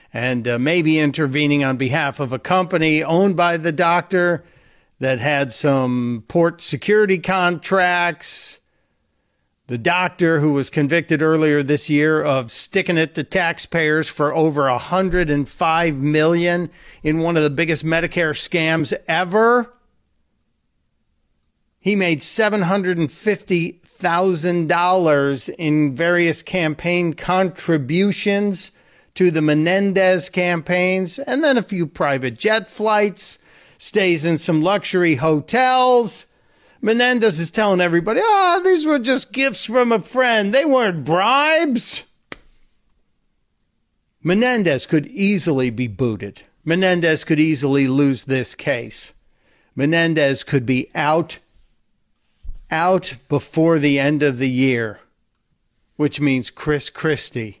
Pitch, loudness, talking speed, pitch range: 165 Hz, -18 LUFS, 115 wpm, 145-185 Hz